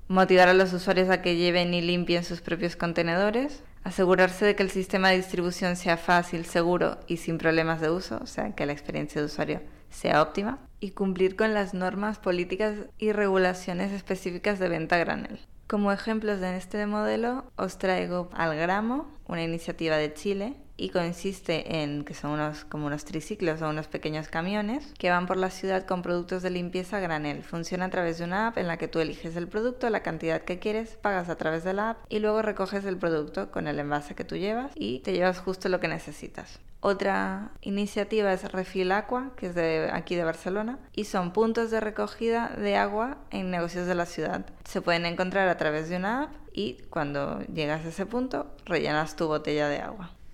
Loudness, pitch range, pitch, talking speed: -28 LUFS, 170-205 Hz, 185 Hz, 200 wpm